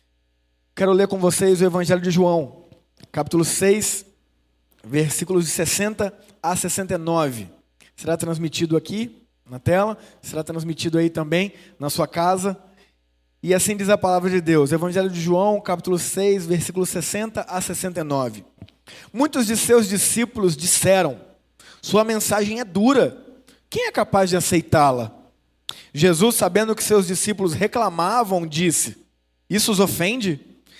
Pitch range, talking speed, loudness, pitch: 160-200 Hz, 130 wpm, -20 LUFS, 180 Hz